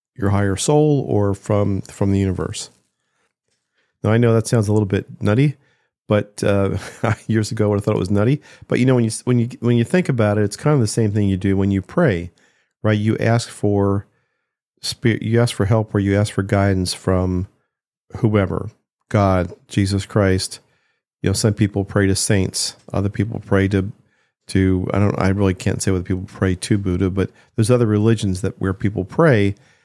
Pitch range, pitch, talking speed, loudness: 95-115 Hz, 105 Hz, 200 wpm, -19 LUFS